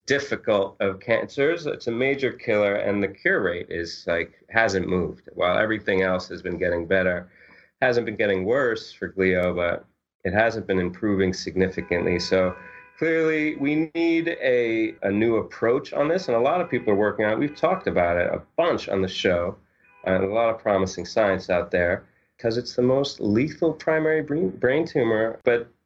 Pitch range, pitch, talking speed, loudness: 95-130 Hz, 105 Hz, 185 wpm, -23 LUFS